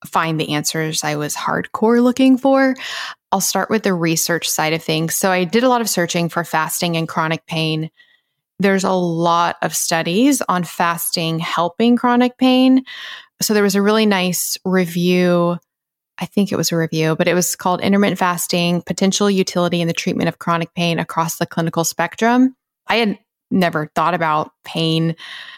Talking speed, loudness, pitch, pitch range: 175 wpm, -17 LUFS, 175 Hz, 165-205 Hz